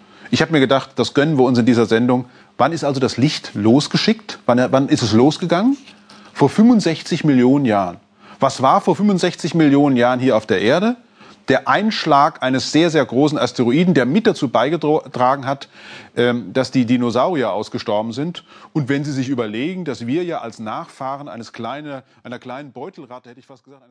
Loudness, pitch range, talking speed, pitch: -17 LUFS, 125-165 Hz, 180 wpm, 140 Hz